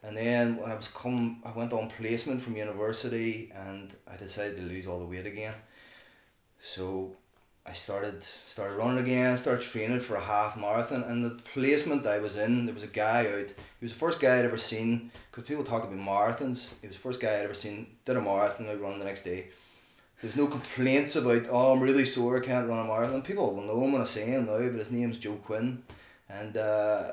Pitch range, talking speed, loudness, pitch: 105-125 Hz, 225 wpm, -30 LUFS, 115 Hz